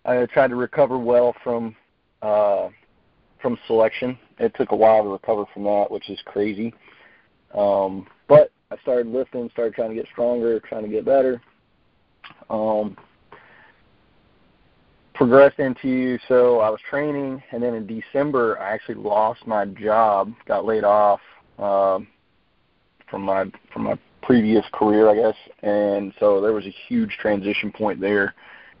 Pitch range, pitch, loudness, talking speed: 105-125 Hz, 110 Hz, -21 LUFS, 150 wpm